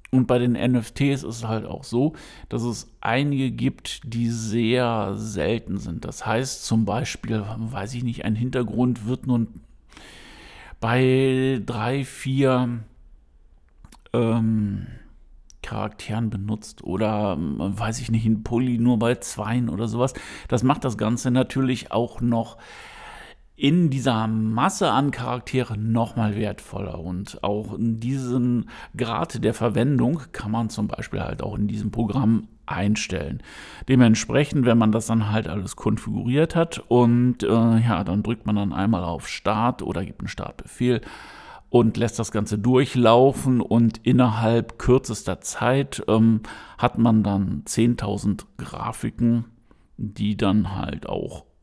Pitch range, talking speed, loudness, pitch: 105-125 Hz, 135 wpm, -23 LUFS, 115 Hz